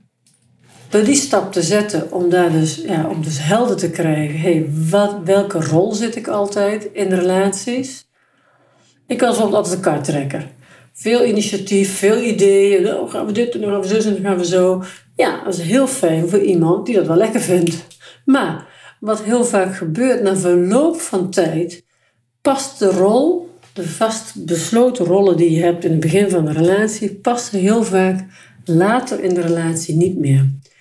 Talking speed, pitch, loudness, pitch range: 175 wpm, 190 Hz, -16 LUFS, 170-215 Hz